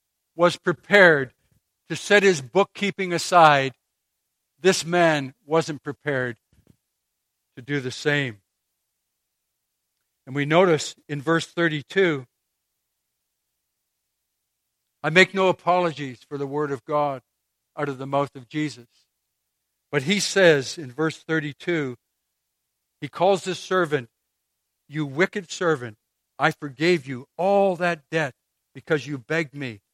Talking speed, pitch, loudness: 120 wpm, 140 Hz, -22 LUFS